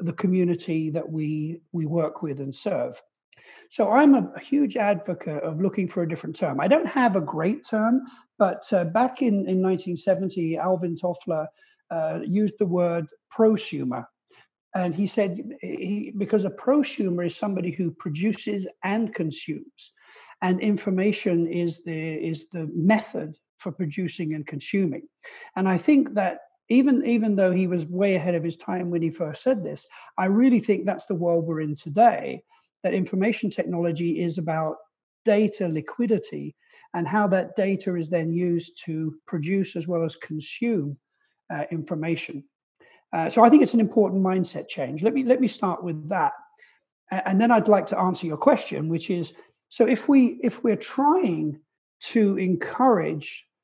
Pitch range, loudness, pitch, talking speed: 170-225 Hz, -24 LUFS, 185 Hz, 165 wpm